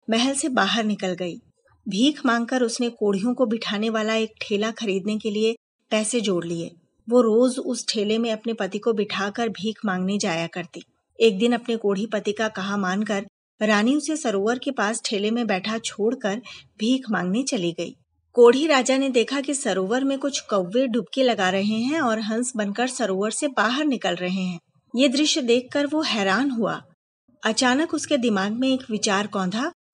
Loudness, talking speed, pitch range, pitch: -23 LUFS, 180 wpm, 205-250 Hz, 225 Hz